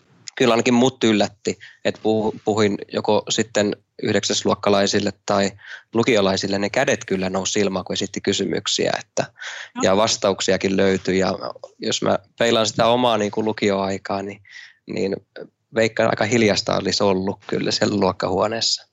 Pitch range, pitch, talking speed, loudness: 95-110 Hz, 100 Hz, 135 wpm, -20 LUFS